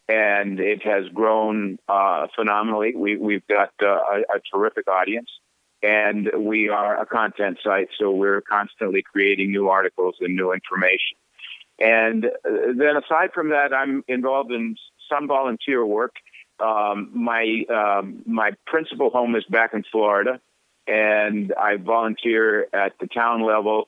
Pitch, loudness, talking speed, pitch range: 110 Hz, -21 LUFS, 145 wpm, 105-115 Hz